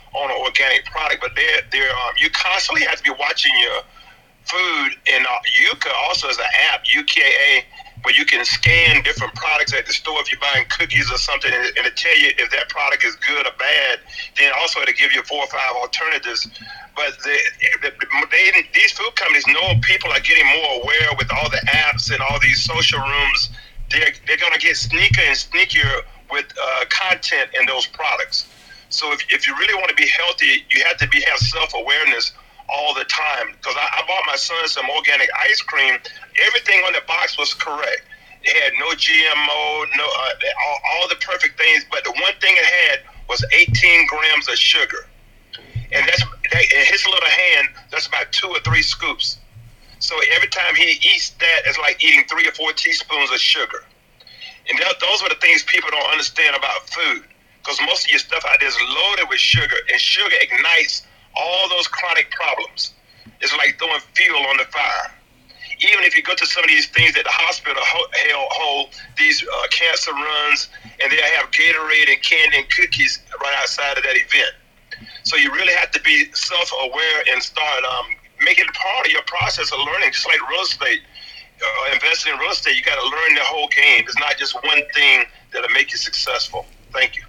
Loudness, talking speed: -15 LUFS, 200 wpm